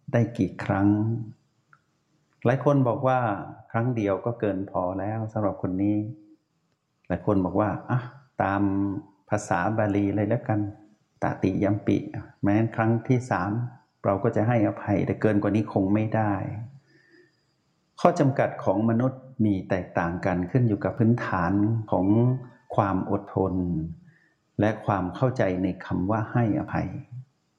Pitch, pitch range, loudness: 110 Hz, 100-120 Hz, -26 LUFS